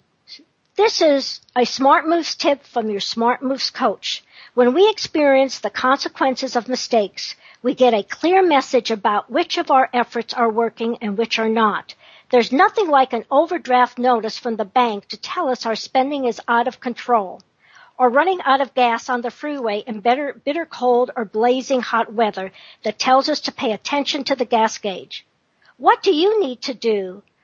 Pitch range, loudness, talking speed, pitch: 230-280 Hz, -19 LUFS, 180 wpm, 250 Hz